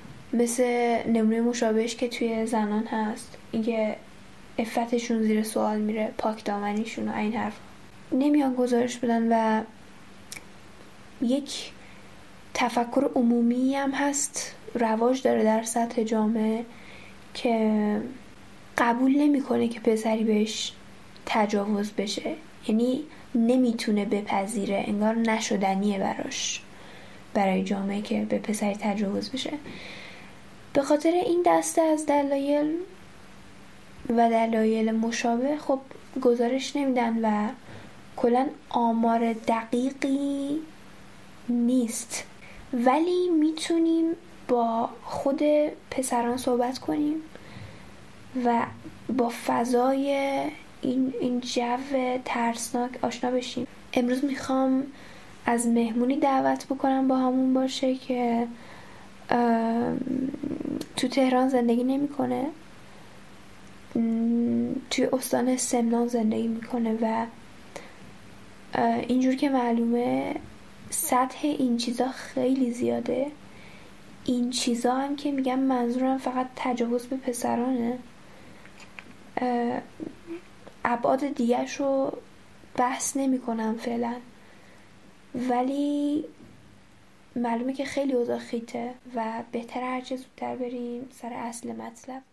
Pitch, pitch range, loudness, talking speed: 245 Hz, 230-265 Hz, -26 LUFS, 95 wpm